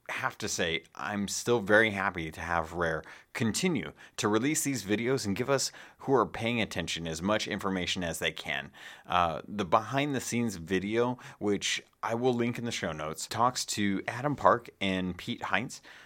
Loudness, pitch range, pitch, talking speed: -30 LUFS, 95-120 Hz, 105 Hz, 185 wpm